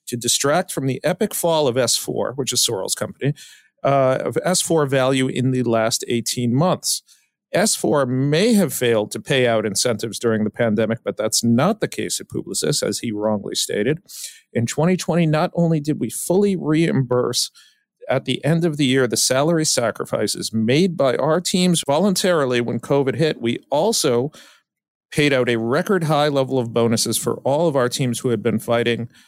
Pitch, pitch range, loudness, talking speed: 130 Hz, 120-160 Hz, -19 LUFS, 180 wpm